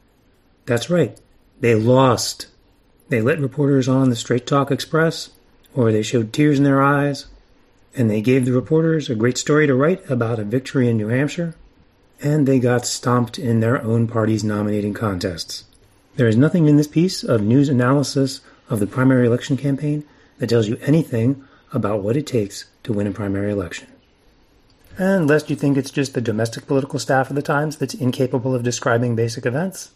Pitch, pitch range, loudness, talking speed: 130 Hz, 115-145 Hz, -19 LUFS, 180 wpm